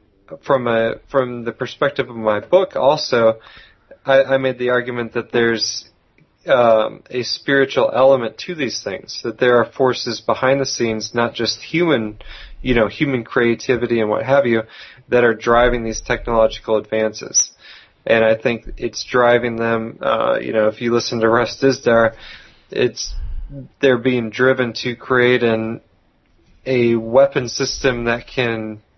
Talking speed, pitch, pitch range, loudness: 155 wpm, 120 Hz, 110-130 Hz, -17 LUFS